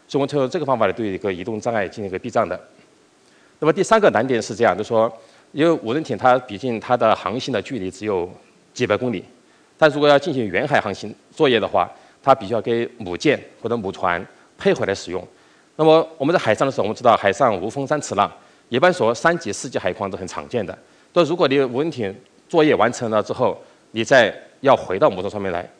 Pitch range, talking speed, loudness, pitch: 115-160 Hz, 340 characters per minute, -20 LUFS, 140 Hz